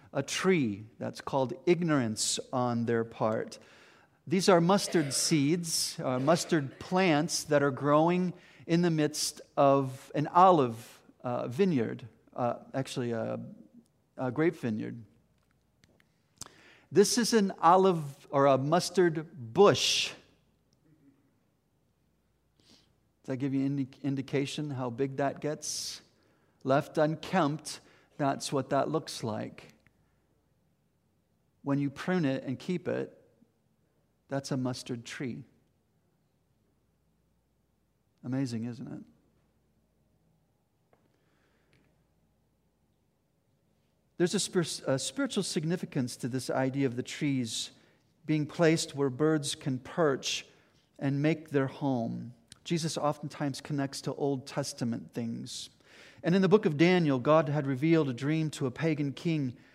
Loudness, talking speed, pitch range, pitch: -30 LUFS, 115 wpm, 130-165 Hz, 145 Hz